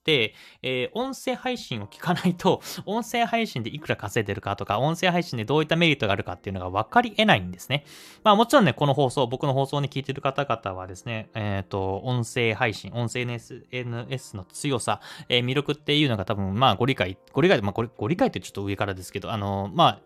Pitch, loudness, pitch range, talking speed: 125 Hz, -25 LUFS, 105-150 Hz, 445 characters per minute